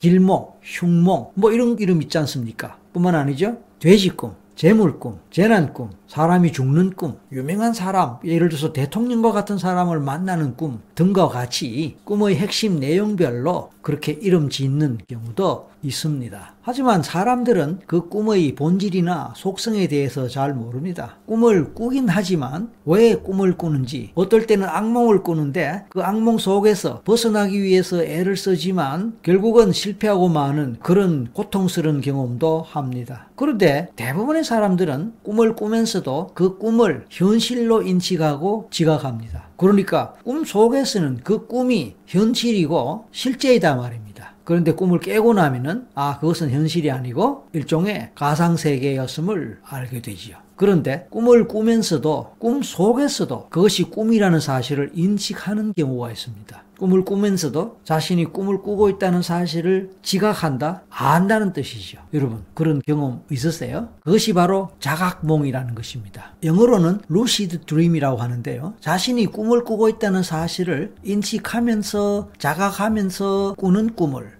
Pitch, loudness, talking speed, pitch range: 180 Hz, -19 LUFS, 325 characters per minute, 150-210 Hz